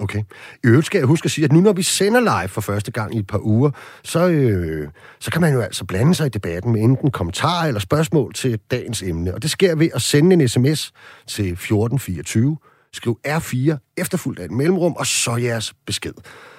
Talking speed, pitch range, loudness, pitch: 215 wpm, 105-160 Hz, -19 LUFS, 130 Hz